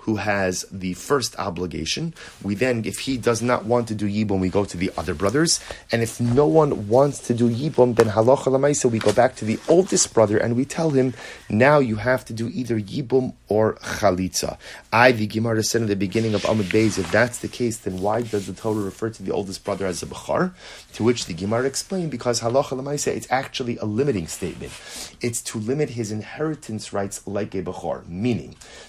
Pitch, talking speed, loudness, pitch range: 115 Hz, 210 wpm, -22 LUFS, 105-130 Hz